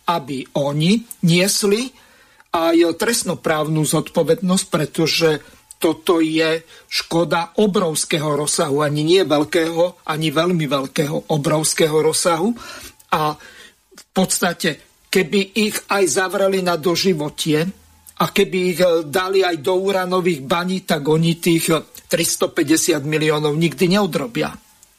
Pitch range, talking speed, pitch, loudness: 160-190 Hz, 105 wpm, 170 Hz, -18 LUFS